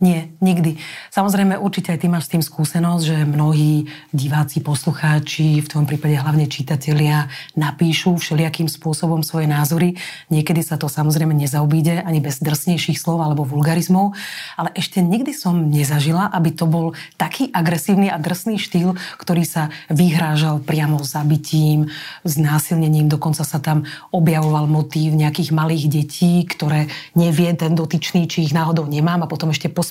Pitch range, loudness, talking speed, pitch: 150-170 Hz, -18 LUFS, 150 wpm, 160 Hz